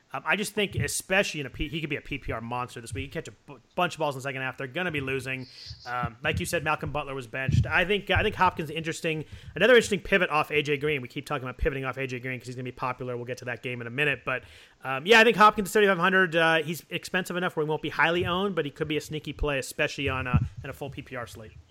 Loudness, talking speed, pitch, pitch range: -26 LUFS, 290 wpm, 145 Hz, 130-165 Hz